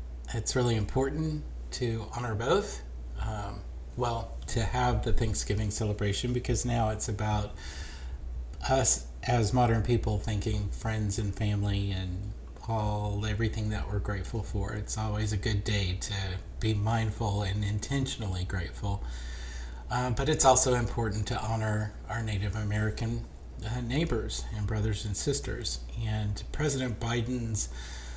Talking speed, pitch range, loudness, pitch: 130 wpm, 100-115 Hz, -31 LUFS, 105 Hz